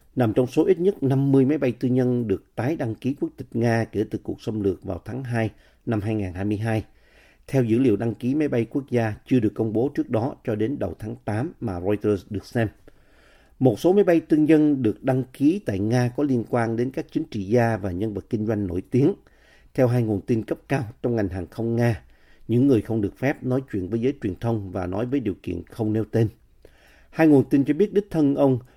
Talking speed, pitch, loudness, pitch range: 240 wpm, 120 Hz, -23 LUFS, 110-135 Hz